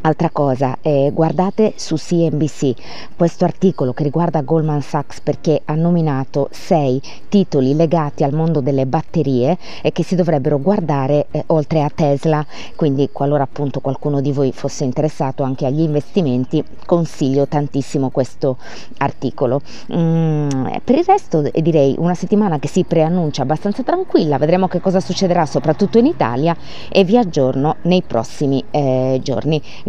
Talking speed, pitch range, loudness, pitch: 145 wpm, 140-170 Hz, -17 LUFS, 150 Hz